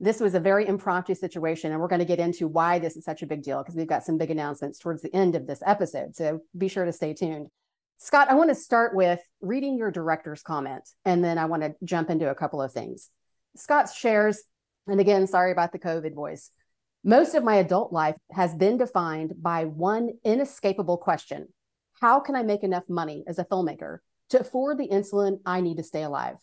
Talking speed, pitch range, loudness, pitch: 220 wpm, 160-205 Hz, -25 LUFS, 180 Hz